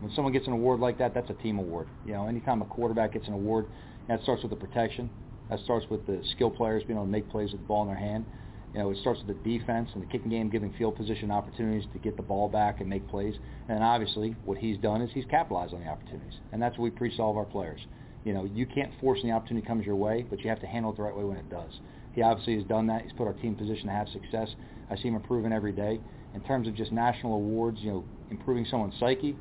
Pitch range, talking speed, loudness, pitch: 105-120 Hz, 280 wpm, -31 LUFS, 110 Hz